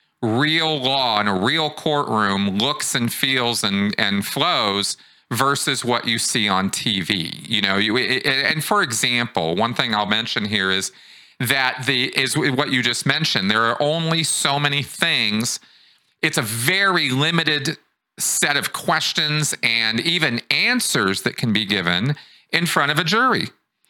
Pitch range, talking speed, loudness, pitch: 115-155 Hz, 155 wpm, -19 LUFS, 130 Hz